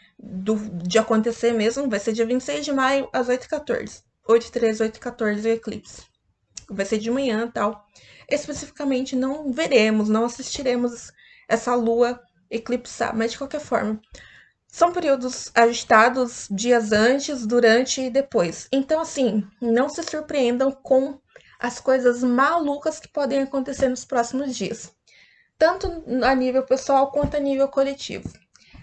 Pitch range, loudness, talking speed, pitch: 230-275 Hz, -22 LUFS, 130 wpm, 250 Hz